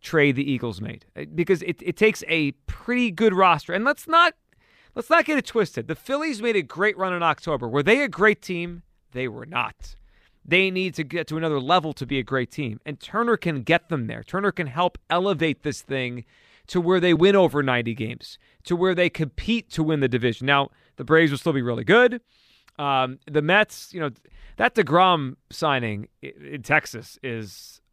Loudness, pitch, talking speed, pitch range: -22 LUFS, 160 Hz, 200 wpm, 135-190 Hz